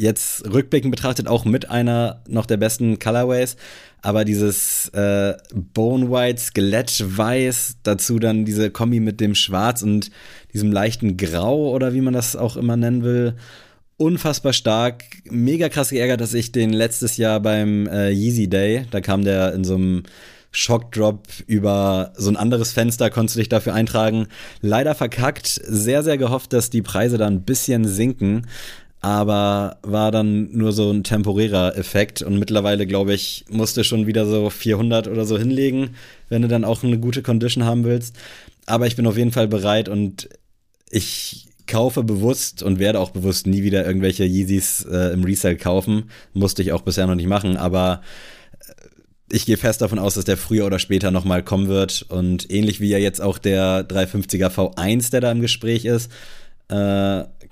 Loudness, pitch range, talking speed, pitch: -19 LUFS, 100-120 Hz, 175 wpm, 110 Hz